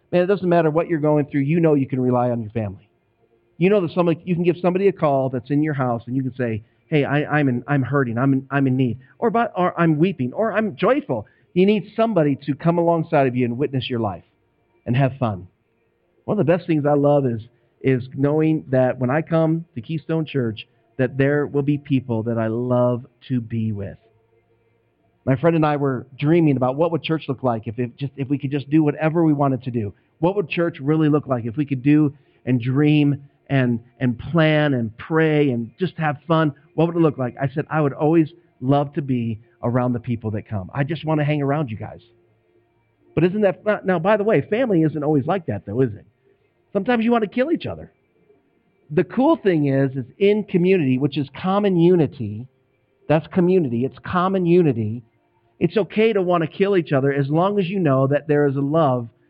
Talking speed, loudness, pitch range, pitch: 225 wpm, -20 LUFS, 125-170 Hz, 145 Hz